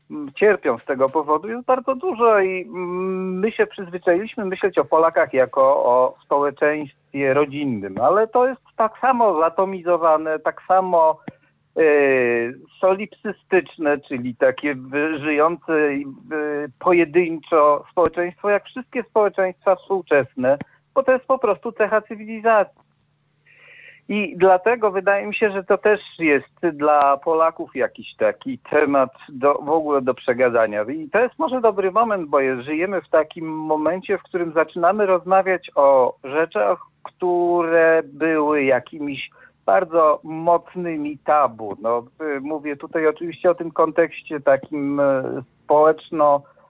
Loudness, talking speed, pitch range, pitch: -20 LUFS, 125 wpm, 150-200 Hz, 165 Hz